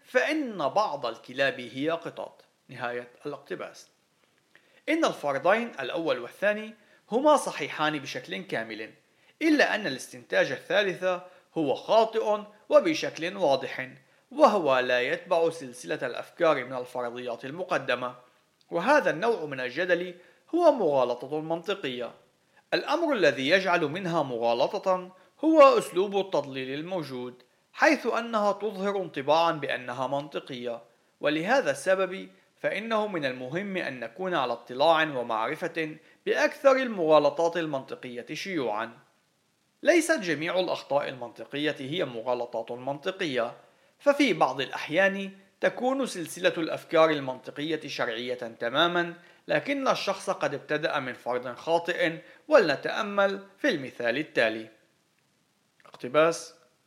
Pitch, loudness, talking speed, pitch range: 170 Hz, -27 LUFS, 100 wpm, 135-200 Hz